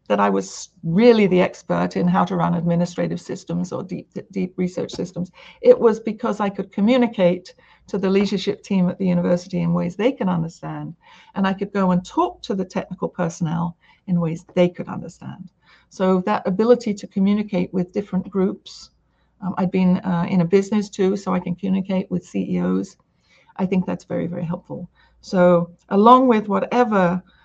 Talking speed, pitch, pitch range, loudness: 180 wpm, 185 Hz, 175-200 Hz, -20 LUFS